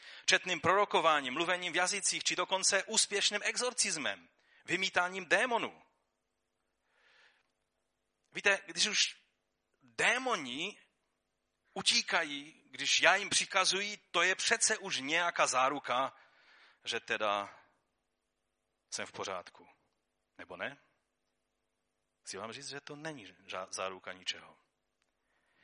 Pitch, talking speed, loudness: 160 Hz, 95 wpm, -31 LUFS